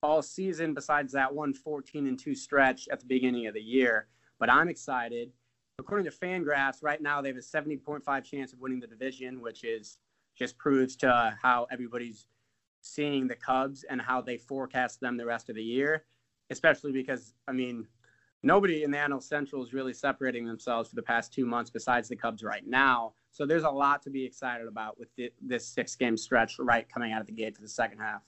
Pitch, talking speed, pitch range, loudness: 130 Hz, 215 wpm, 120-140 Hz, -30 LUFS